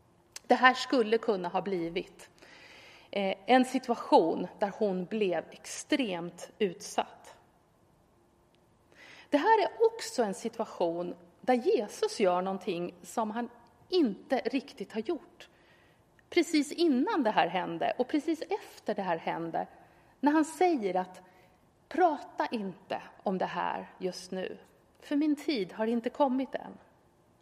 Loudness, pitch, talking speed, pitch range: -31 LUFS, 240 Hz, 125 wpm, 190-300 Hz